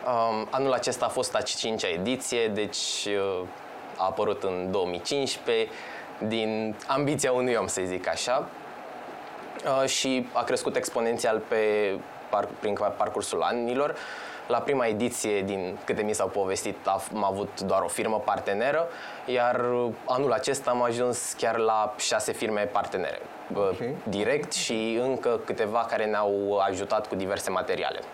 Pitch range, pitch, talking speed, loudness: 100-120 Hz, 110 Hz, 130 wpm, -28 LUFS